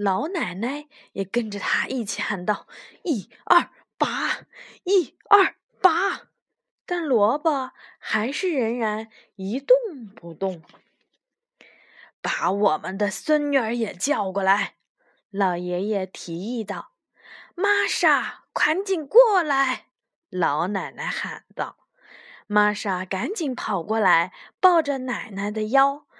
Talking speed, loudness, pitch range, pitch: 160 characters per minute, -23 LUFS, 200-300 Hz, 230 Hz